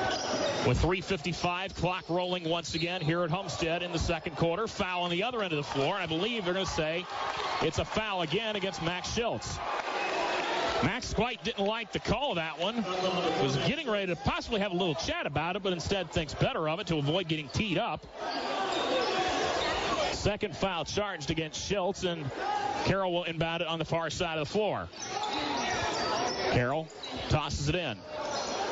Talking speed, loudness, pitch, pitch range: 180 wpm, -31 LUFS, 175 Hz, 165-195 Hz